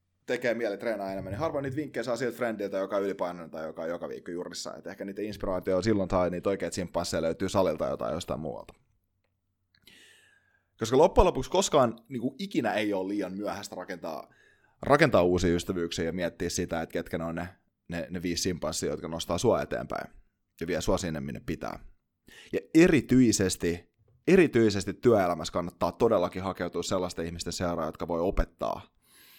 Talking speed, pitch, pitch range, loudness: 170 wpm, 95 Hz, 85-110 Hz, -29 LUFS